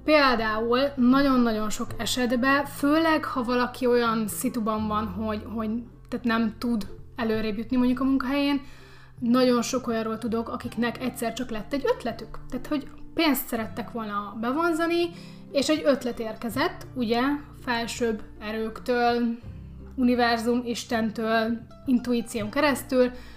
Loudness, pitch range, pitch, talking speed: -26 LUFS, 225-265 Hz, 240 Hz, 120 wpm